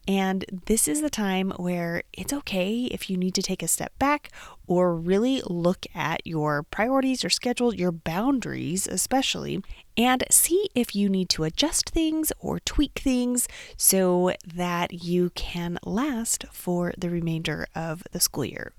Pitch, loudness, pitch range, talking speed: 190 Hz, -25 LUFS, 175-250 Hz, 160 wpm